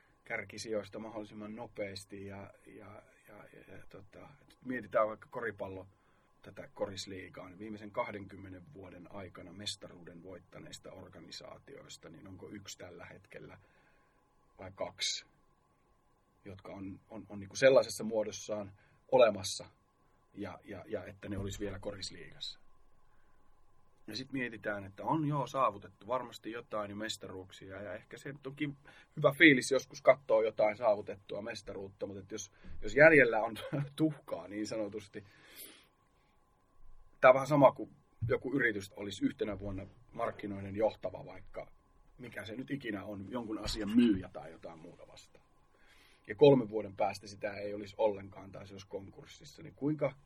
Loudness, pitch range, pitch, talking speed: -33 LUFS, 100-120 Hz, 105 Hz, 140 wpm